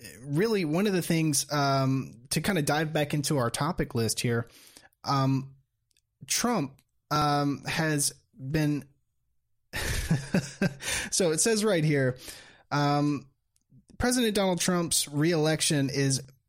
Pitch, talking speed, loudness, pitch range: 145 Hz, 115 wpm, -27 LUFS, 130-155 Hz